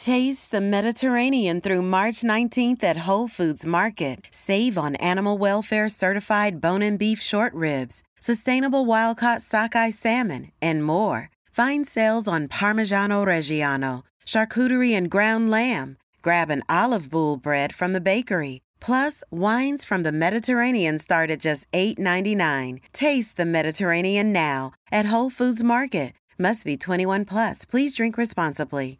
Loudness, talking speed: -22 LUFS, 140 wpm